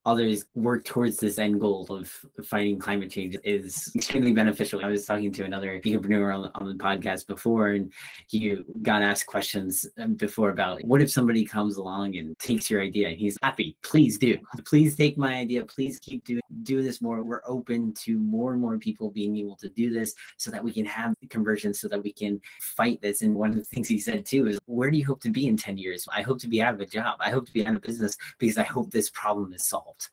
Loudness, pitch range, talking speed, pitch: -27 LUFS, 100-125 Hz, 240 wpm, 110 Hz